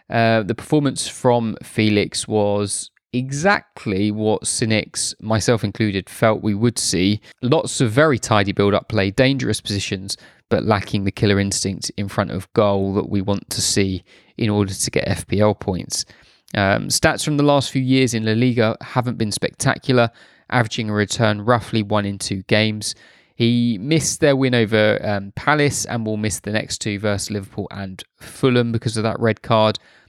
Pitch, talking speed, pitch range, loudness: 110 Hz, 175 wpm, 105-120 Hz, -19 LUFS